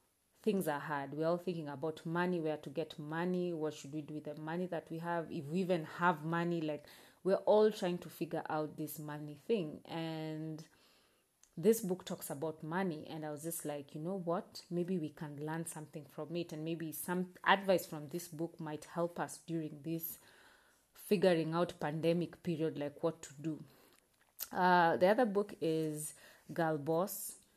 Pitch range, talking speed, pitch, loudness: 155-175 Hz, 185 wpm, 165 Hz, -37 LUFS